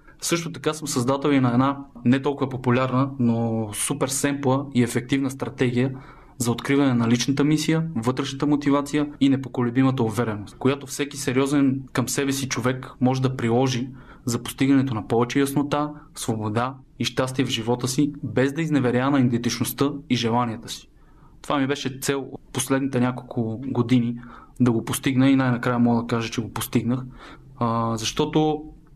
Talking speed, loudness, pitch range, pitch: 155 wpm, -23 LUFS, 120-140 Hz, 130 Hz